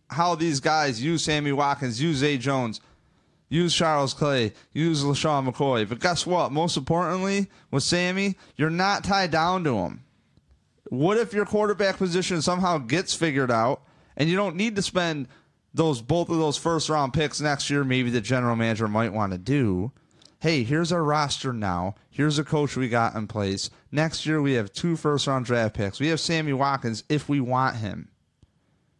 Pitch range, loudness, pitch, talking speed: 130-170 Hz, -25 LUFS, 150 Hz, 185 wpm